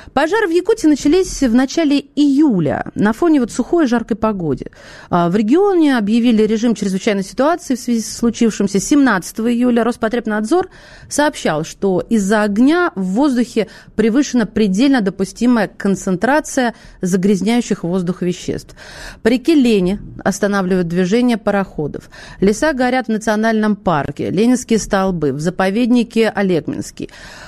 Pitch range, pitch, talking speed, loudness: 195-255 Hz, 225 Hz, 120 wpm, -16 LUFS